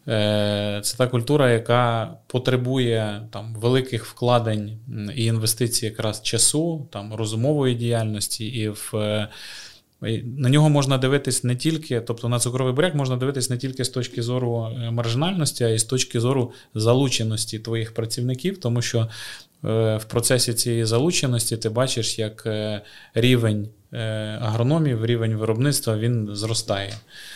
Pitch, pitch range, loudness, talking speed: 120 Hz, 110-130 Hz, -22 LUFS, 125 wpm